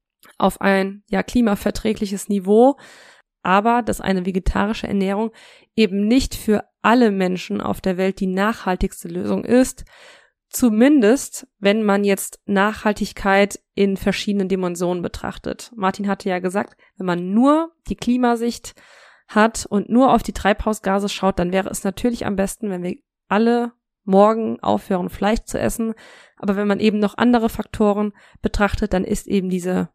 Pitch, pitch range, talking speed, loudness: 205 Hz, 195-225 Hz, 145 wpm, -20 LUFS